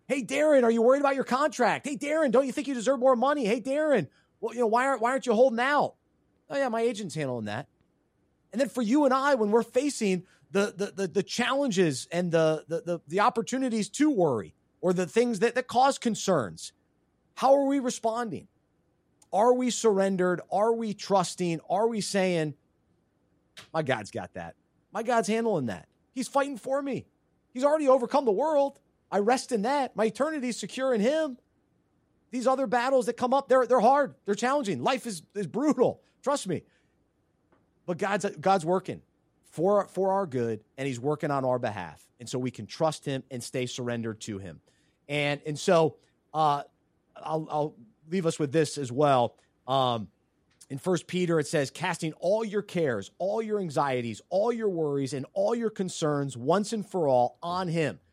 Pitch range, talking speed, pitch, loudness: 155-250 Hz, 190 wpm, 200 Hz, -27 LUFS